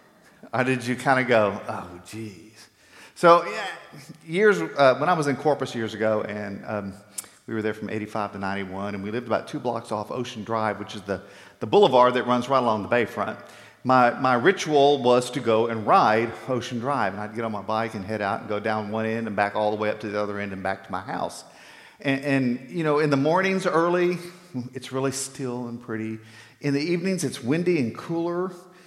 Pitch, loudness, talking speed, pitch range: 120 Hz, -24 LUFS, 220 wpm, 105-140 Hz